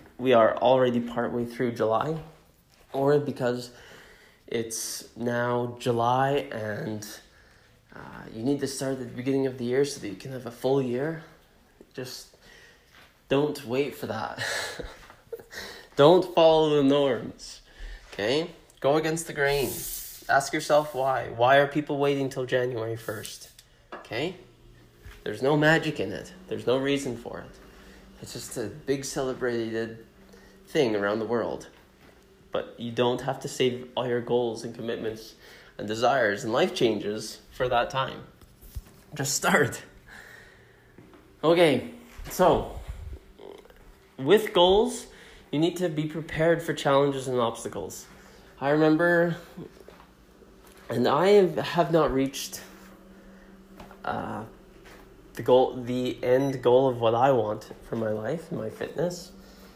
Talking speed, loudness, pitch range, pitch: 135 wpm, -26 LUFS, 120-155 Hz, 135 Hz